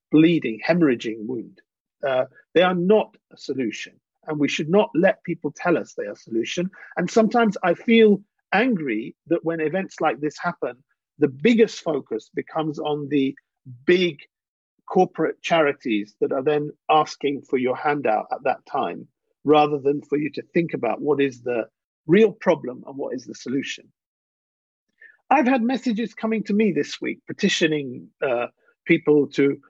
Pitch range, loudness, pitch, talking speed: 150-205 Hz, -22 LUFS, 165 Hz, 160 wpm